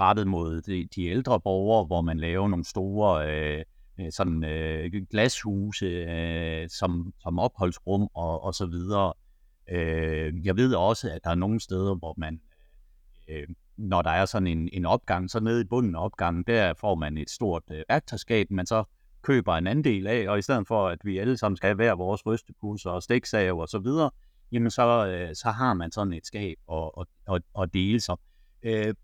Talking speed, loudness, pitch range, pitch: 195 wpm, -27 LUFS, 85-110 Hz, 95 Hz